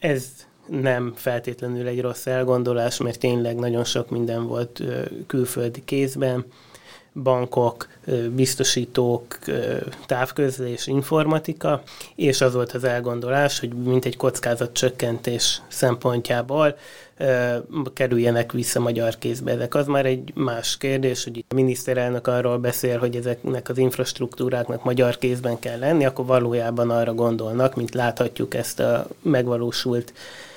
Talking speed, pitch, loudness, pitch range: 120 wpm, 125 Hz, -23 LUFS, 120-130 Hz